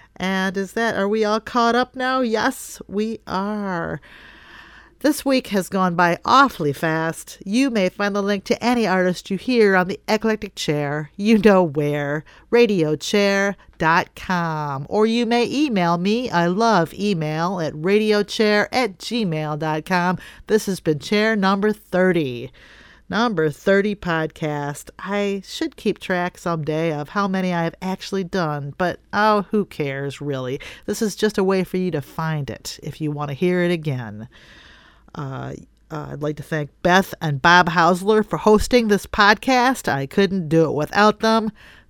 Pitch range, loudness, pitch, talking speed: 160-215 Hz, -20 LUFS, 190 Hz, 160 wpm